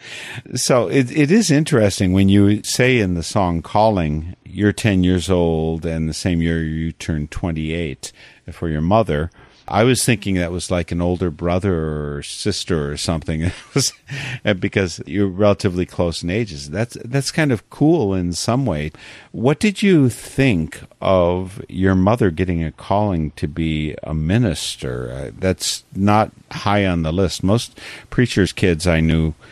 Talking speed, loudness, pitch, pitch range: 160 wpm, -19 LUFS, 95 Hz, 80-110 Hz